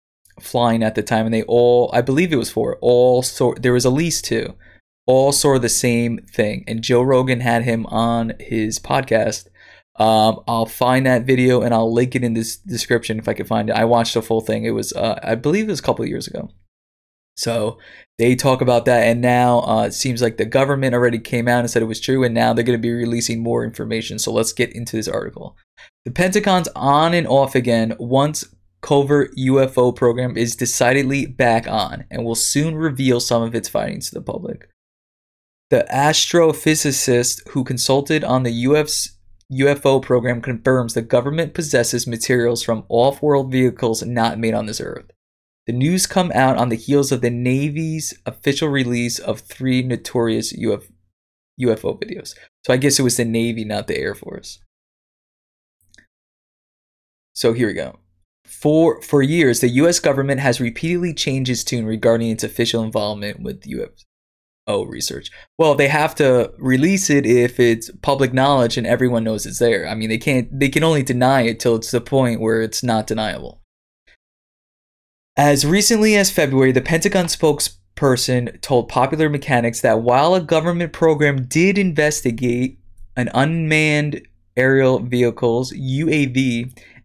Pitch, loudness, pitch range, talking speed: 120 Hz, -18 LUFS, 115-135 Hz, 170 wpm